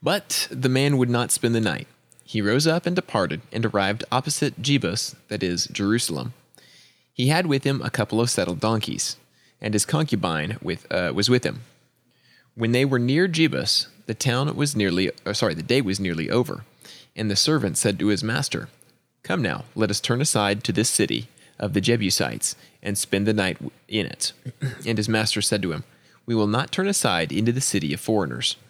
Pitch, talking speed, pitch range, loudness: 115 Hz, 195 wpm, 105-135 Hz, -23 LUFS